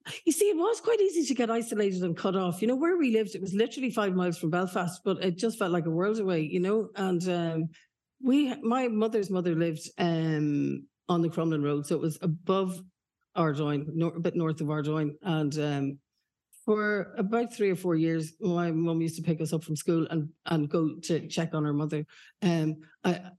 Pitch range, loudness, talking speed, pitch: 160-210 Hz, -29 LUFS, 215 wpm, 175 Hz